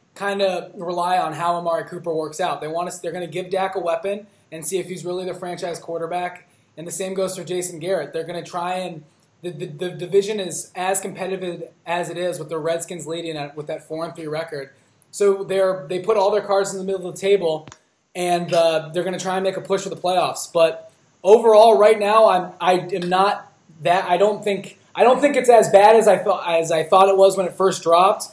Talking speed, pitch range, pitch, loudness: 245 wpm, 170-195 Hz, 180 Hz, -20 LUFS